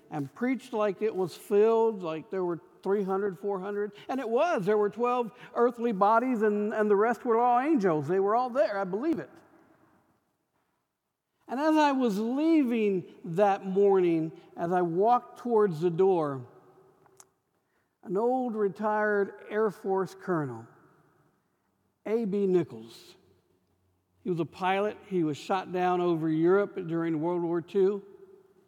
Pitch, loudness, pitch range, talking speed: 200 Hz, -28 LUFS, 175-225 Hz, 140 wpm